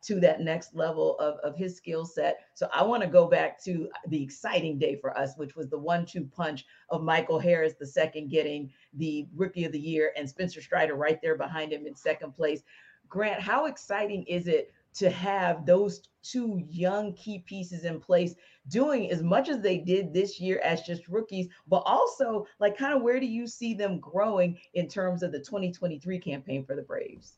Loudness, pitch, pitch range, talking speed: -29 LUFS, 175 Hz, 155-200 Hz, 205 wpm